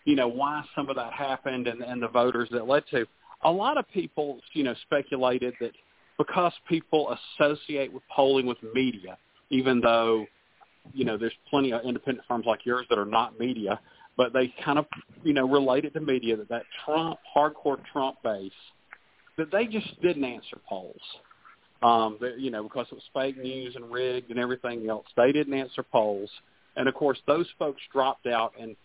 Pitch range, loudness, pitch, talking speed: 120-145 Hz, -28 LUFS, 130 Hz, 190 wpm